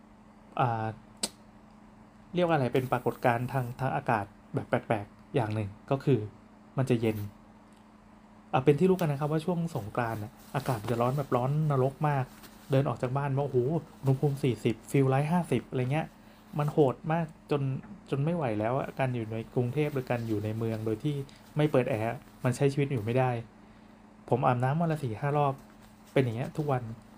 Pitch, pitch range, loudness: 130 Hz, 115-145 Hz, -30 LUFS